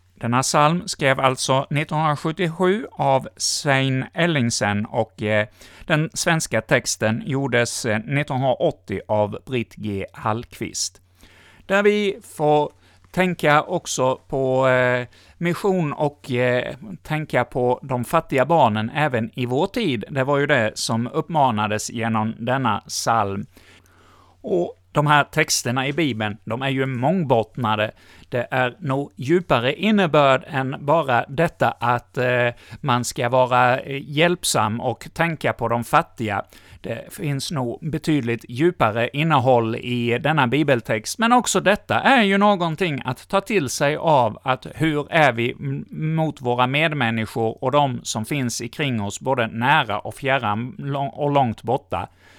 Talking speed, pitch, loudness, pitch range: 130 wpm, 130 Hz, -21 LUFS, 115-150 Hz